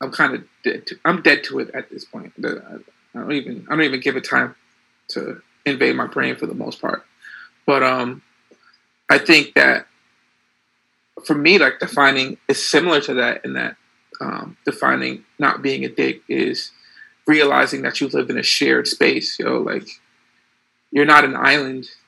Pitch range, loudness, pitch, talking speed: 130-145 Hz, -17 LUFS, 135 Hz, 180 wpm